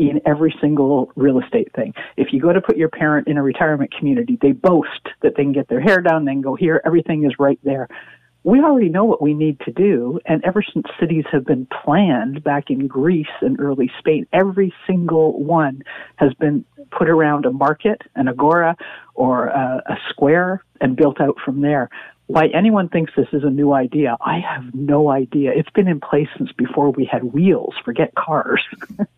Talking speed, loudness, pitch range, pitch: 200 wpm, -17 LUFS, 140-170 Hz, 150 Hz